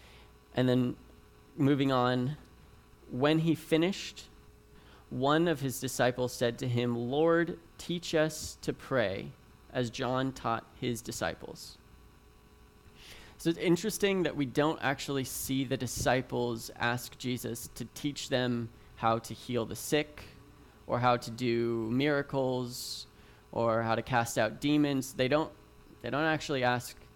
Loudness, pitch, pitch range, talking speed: -32 LUFS, 125 Hz, 115-145 Hz, 135 wpm